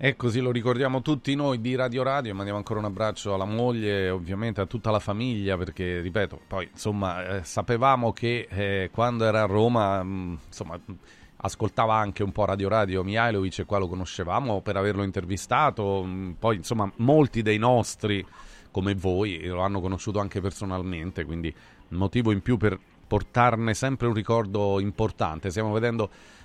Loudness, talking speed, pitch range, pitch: -26 LUFS, 170 wpm, 95-115 Hz, 105 Hz